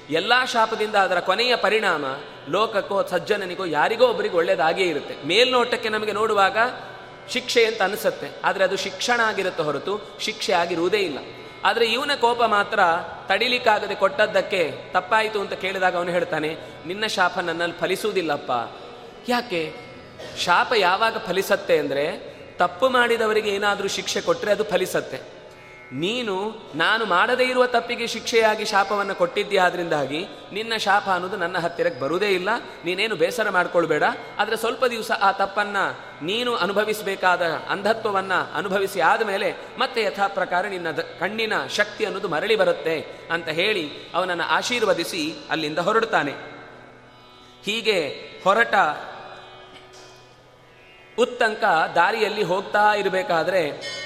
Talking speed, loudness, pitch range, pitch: 115 wpm, -22 LUFS, 185-235 Hz, 205 Hz